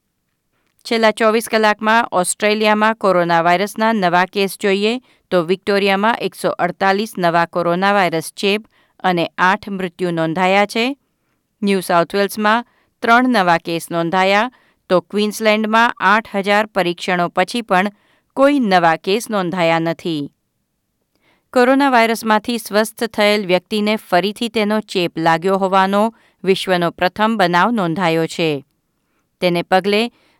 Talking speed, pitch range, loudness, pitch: 115 wpm, 180-220 Hz, -16 LUFS, 200 Hz